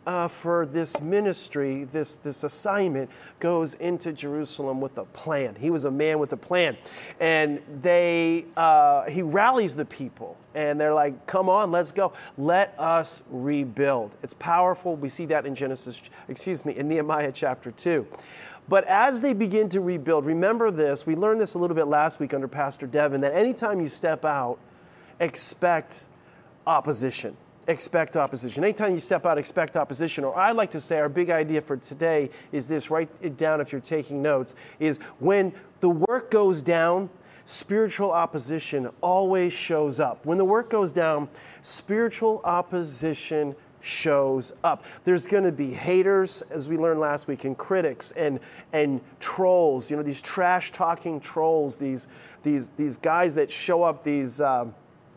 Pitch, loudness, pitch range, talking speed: 160 Hz, -25 LUFS, 145-180 Hz, 165 wpm